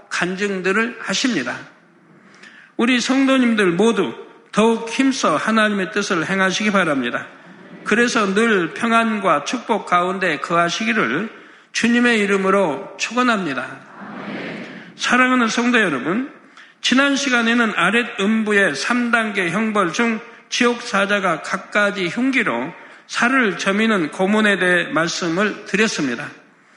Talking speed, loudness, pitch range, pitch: 260 characters per minute, -18 LUFS, 195-240 Hz, 220 Hz